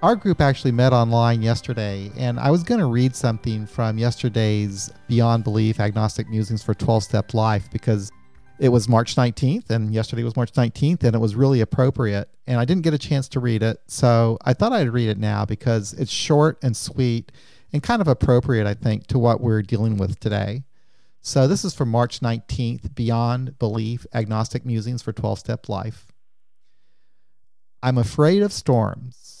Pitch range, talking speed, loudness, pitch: 110-130 Hz, 180 wpm, -21 LUFS, 115 Hz